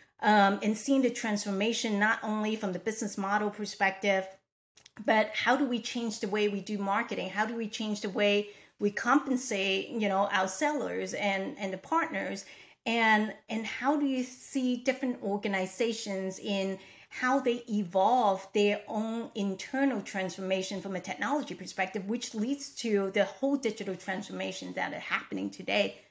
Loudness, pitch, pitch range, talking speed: -30 LUFS, 210 Hz, 195-235 Hz, 160 wpm